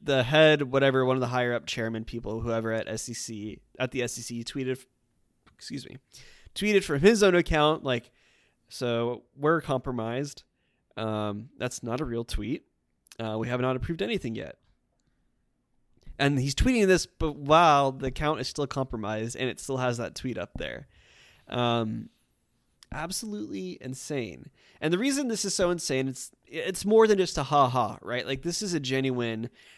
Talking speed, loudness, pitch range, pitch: 170 wpm, -27 LUFS, 115-150 Hz, 130 Hz